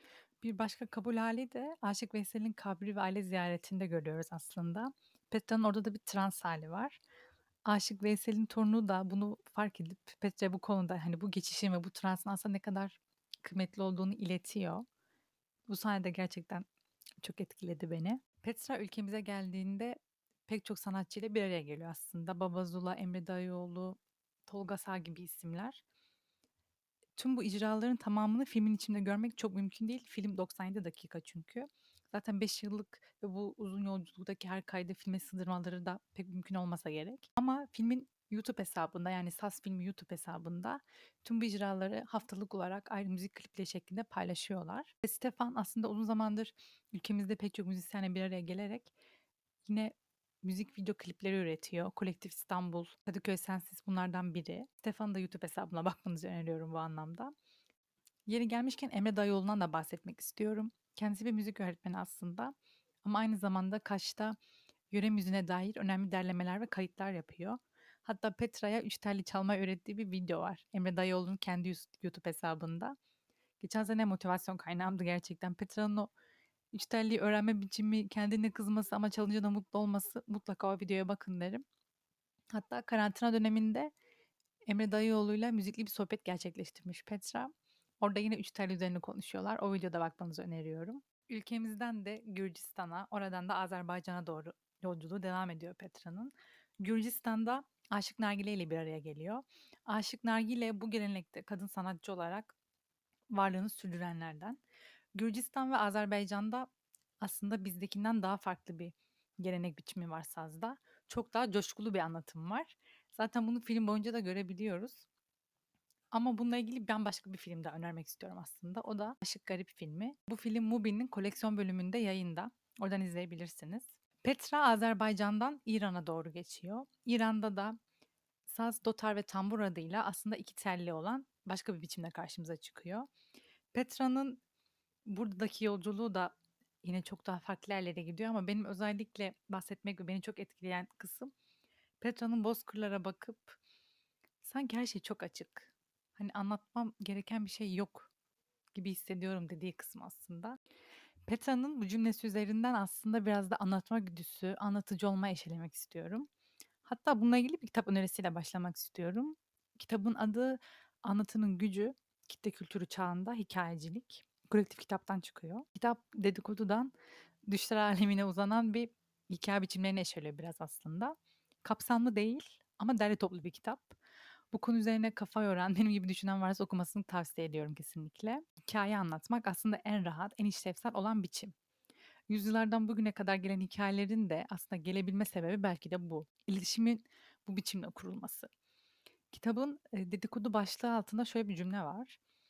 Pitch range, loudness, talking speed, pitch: 185-225 Hz, -39 LUFS, 140 wpm, 205 Hz